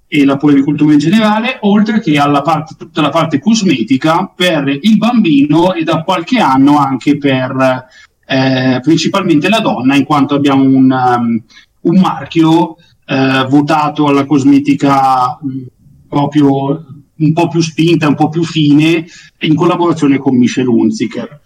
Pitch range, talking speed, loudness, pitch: 135-165 Hz, 135 wpm, -11 LUFS, 150 Hz